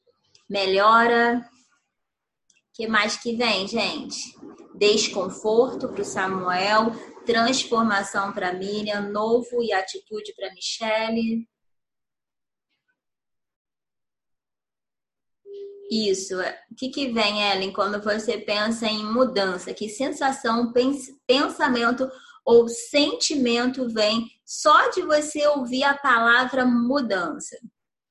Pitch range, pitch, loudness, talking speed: 210-265 Hz, 230 Hz, -22 LUFS, 95 wpm